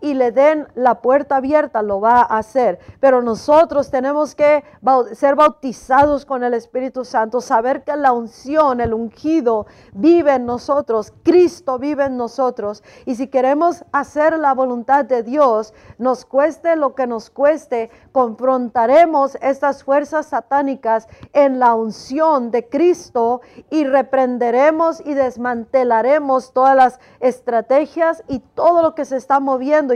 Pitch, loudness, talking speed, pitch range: 265 Hz, -16 LUFS, 140 wpm, 245-290 Hz